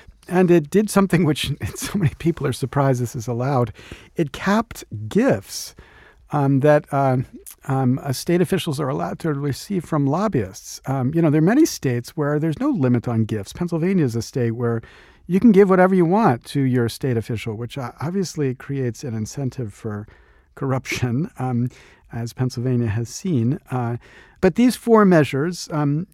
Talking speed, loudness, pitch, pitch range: 170 wpm, -21 LUFS, 135 Hz, 120-165 Hz